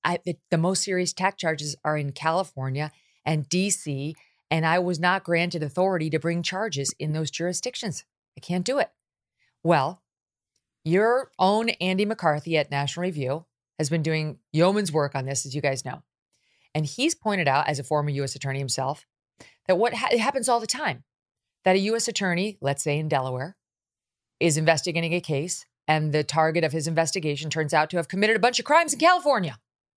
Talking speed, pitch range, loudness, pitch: 180 wpm, 150-190 Hz, -25 LUFS, 165 Hz